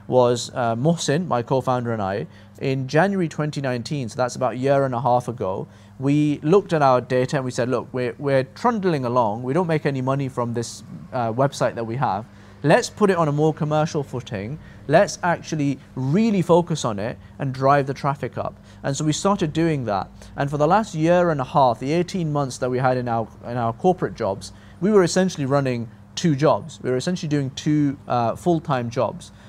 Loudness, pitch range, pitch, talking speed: -22 LUFS, 120-155 Hz, 135 Hz, 215 wpm